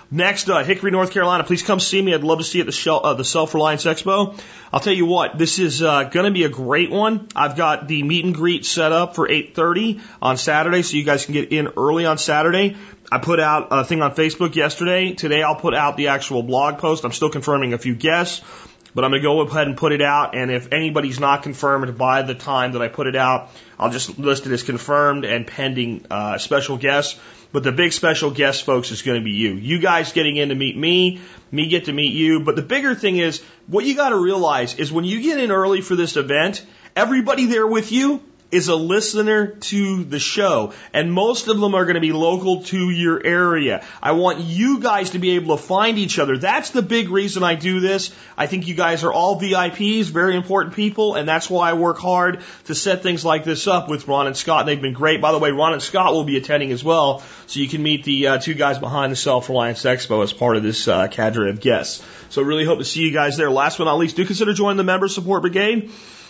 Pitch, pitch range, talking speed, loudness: 160 Hz, 140-185 Hz, 245 wpm, -18 LUFS